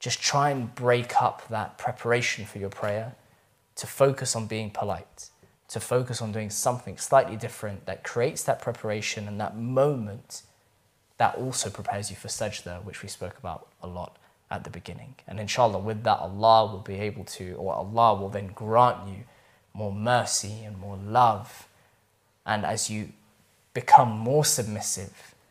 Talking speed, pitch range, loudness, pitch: 165 wpm, 100-120 Hz, -26 LUFS, 110 Hz